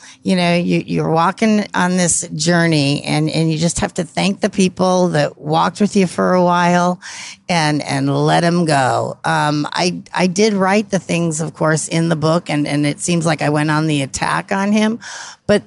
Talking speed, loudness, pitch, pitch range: 205 wpm, -16 LUFS, 170 Hz, 155-185 Hz